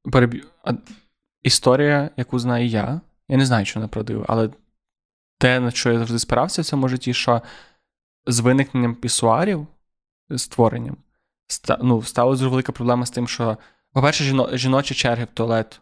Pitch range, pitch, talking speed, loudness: 120-135 Hz, 125 Hz, 145 wpm, -20 LUFS